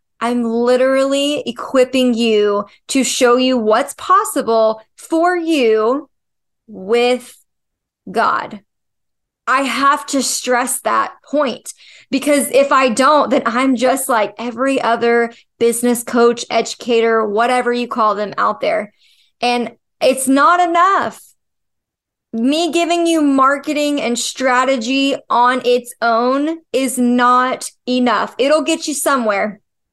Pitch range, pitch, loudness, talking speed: 235-275 Hz, 250 Hz, -15 LUFS, 115 wpm